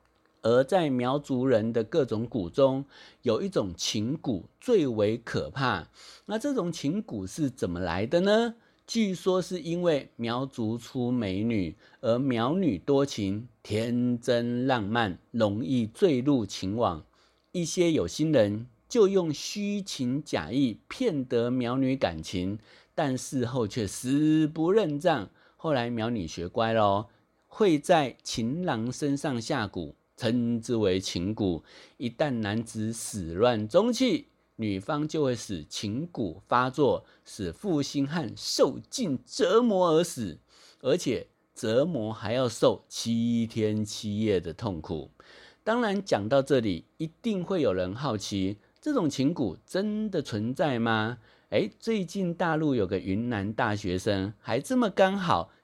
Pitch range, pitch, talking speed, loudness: 105-155 Hz, 120 Hz, 195 characters per minute, -28 LUFS